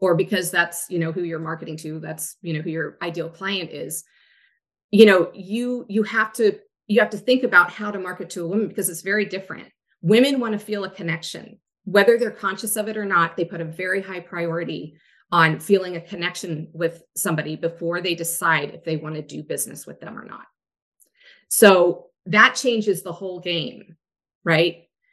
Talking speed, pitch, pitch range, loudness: 200 wpm, 180 Hz, 165-210 Hz, -21 LUFS